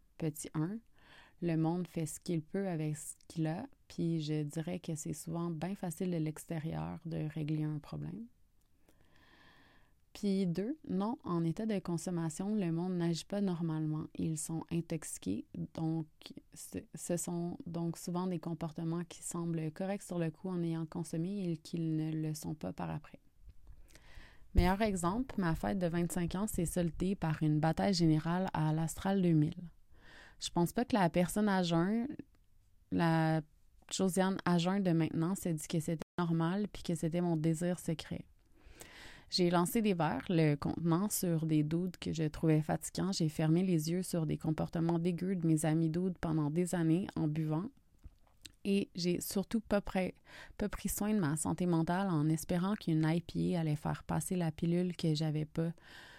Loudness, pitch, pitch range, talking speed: -35 LUFS, 170 Hz, 160-185 Hz, 170 wpm